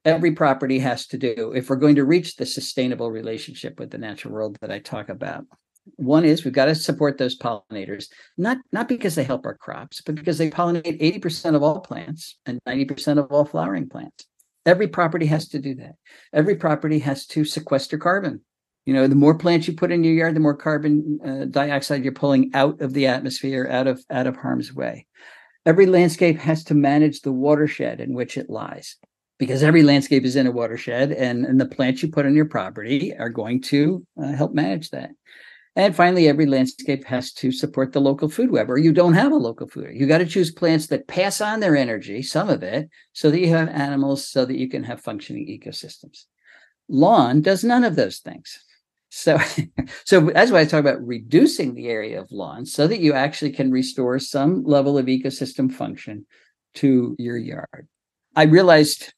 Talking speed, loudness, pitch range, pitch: 205 wpm, -20 LUFS, 130-160 Hz, 145 Hz